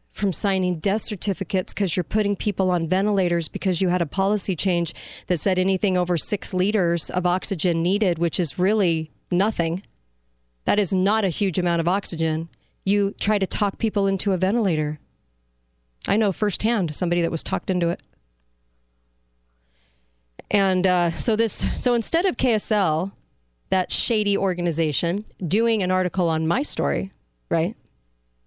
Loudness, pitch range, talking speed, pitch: -22 LUFS, 160-200 Hz, 150 wpm, 180 Hz